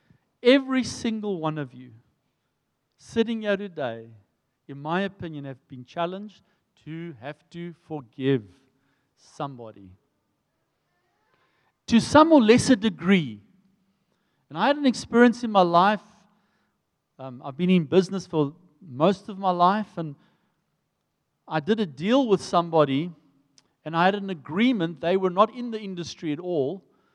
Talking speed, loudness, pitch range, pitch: 135 wpm, -23 LUFS, 145-205 Hz, 175 Hz